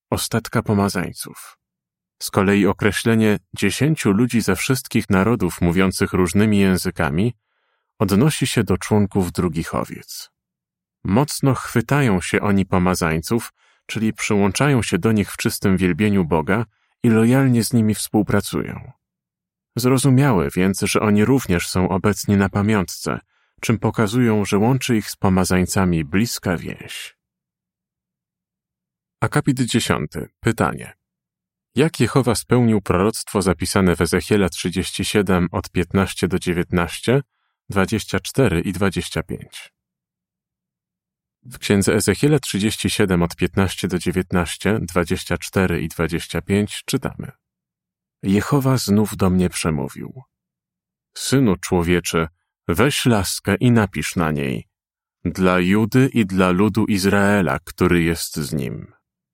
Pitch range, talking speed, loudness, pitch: 90-115 Hz, 110 wpm, -19 LUFS, 100 Hz